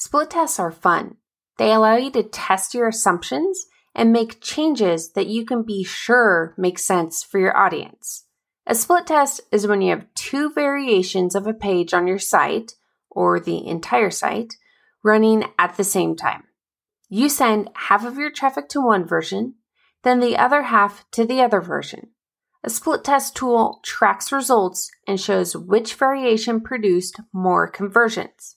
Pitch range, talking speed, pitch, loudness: 190-255 Hz, 165 wpm, 220 Hz, -19 LUFS